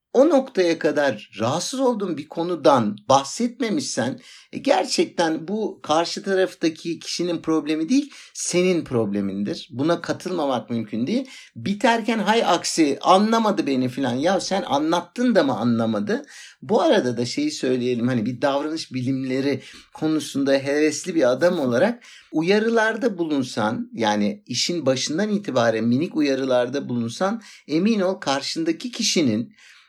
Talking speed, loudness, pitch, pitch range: 120 wpm, -22 LUFS, 165 Hz, 130-215 Hz